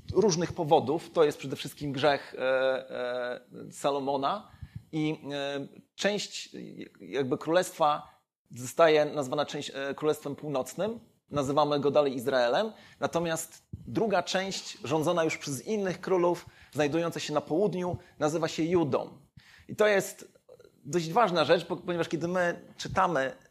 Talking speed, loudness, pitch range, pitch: 115 wpm, -29 LUFS, 140-175 Hz, 155 Hz